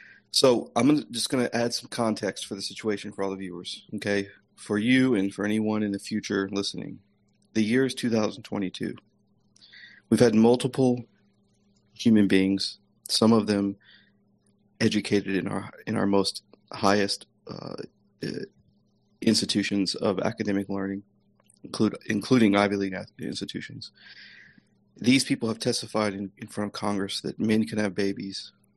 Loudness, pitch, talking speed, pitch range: -26 LUFS, 105 Hz, 145 wpm, 100-110 Hz